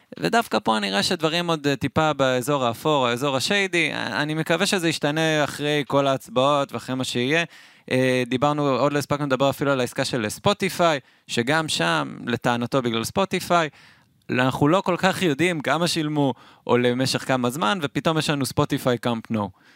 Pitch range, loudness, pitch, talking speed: 125-160 Hz, -22 LUFS, 145 Hz, 160 wpm